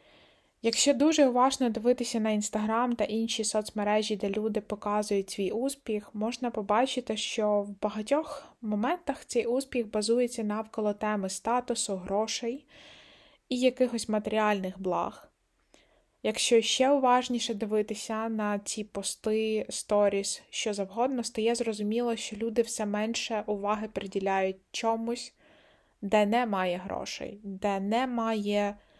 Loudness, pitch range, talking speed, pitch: -29 LUFS, 210-240 Hz, 115 wpm, 220 Hz